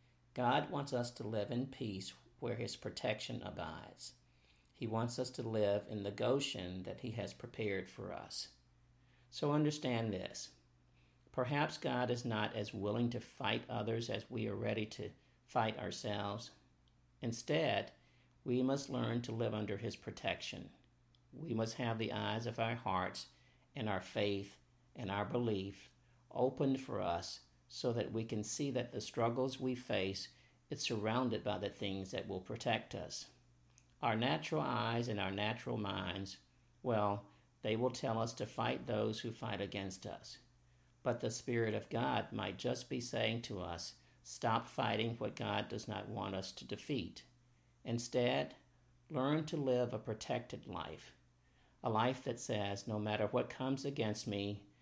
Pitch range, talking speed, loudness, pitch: 100-125 Hz, 160 wpm, -40 LUFS, 110 Hz